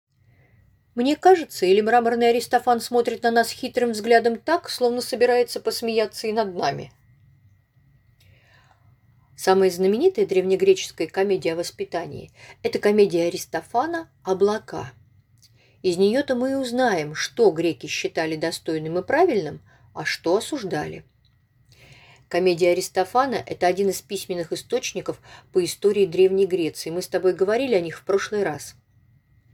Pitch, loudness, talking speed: 190 Hz, -22 LUFS, 125 wpm